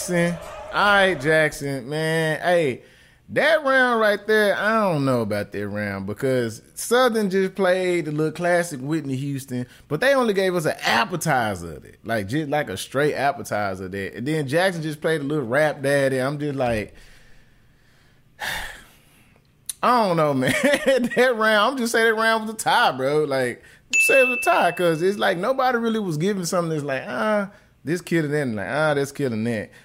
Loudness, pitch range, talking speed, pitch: -21 LUFS, 135-205 Hz, 195 wpm, 160 Hz